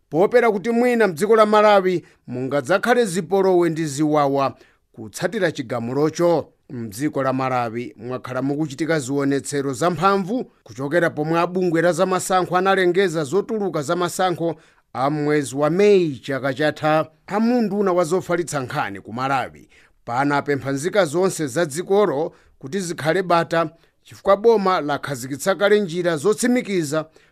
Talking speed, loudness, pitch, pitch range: 105 wpm, -20 LUFS, 170 Hz, 145-195 Hz